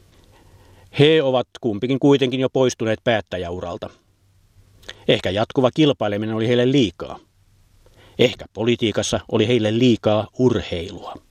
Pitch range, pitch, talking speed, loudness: 100-125 Hz, 110 Hz, 100 wpm, -19 LUFS